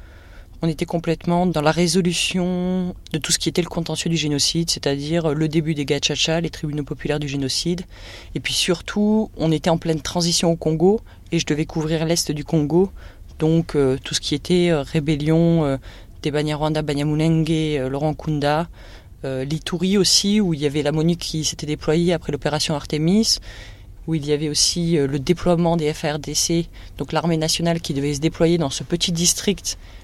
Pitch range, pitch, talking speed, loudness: 150-170 Hz, 160 Hz, 185 wpm, -20 LUFS